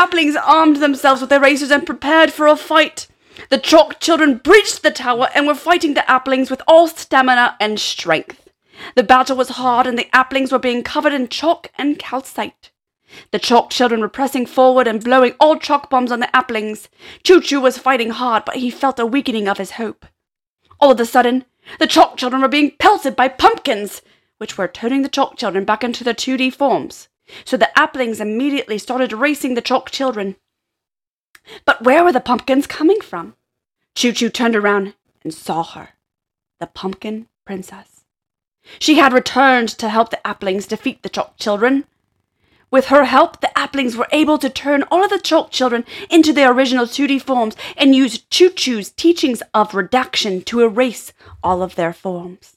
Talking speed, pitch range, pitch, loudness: 185 wpm, 235-290 Hz, 260 Hz, -15 LUFS